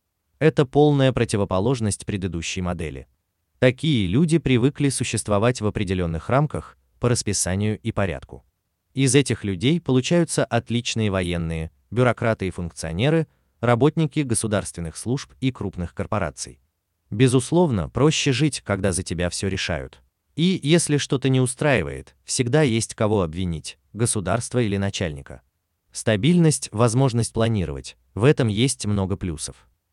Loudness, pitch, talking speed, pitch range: -22 LUFS, 105 Hz, 120 wpm, 90-130 Hz